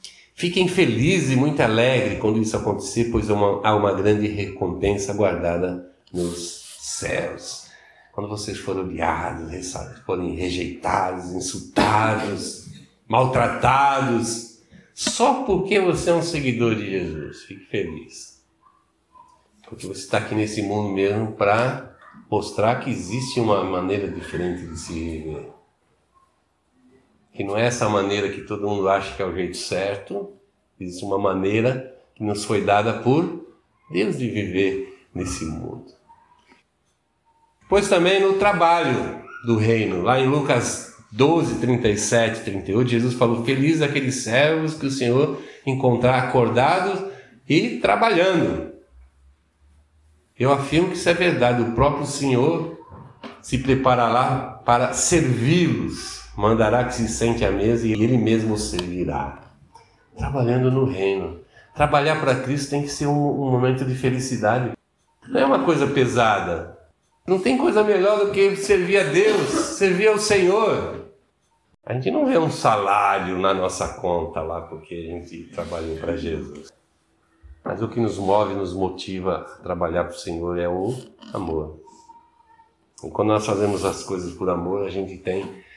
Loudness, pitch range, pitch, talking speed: -21 LUFS, 95-140 Hz, 115 Hz, 140 wpm